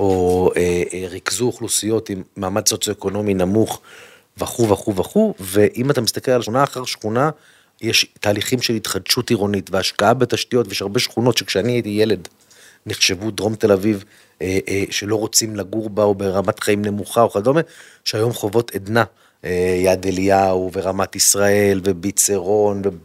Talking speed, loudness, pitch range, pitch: 150 wpm, -18 LUFS, 95-115 Hz, 105 Hz